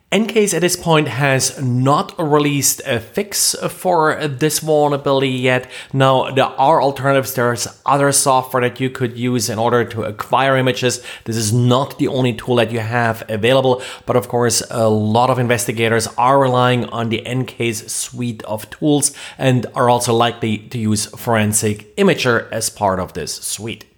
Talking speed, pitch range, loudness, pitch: 170 wpm, 115-140 Hz, -16 LUFS, 125 Hz